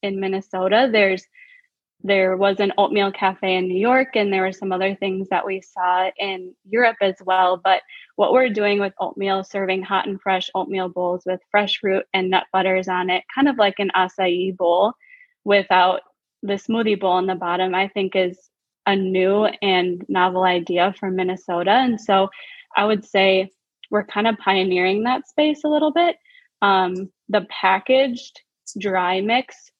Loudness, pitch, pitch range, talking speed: -20 LUFS, 195 Hz, 185-210 Hz, 170 wpm